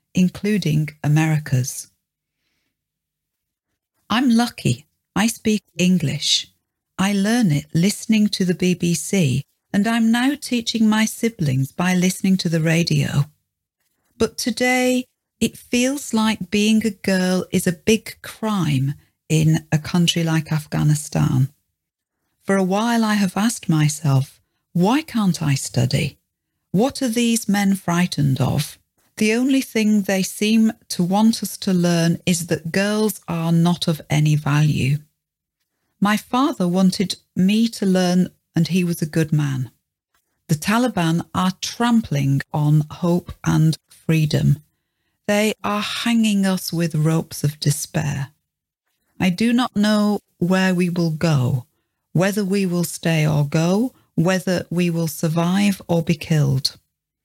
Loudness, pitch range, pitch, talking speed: -20 LUFS, 150-210 Hz, 175 Hz, 130 wpm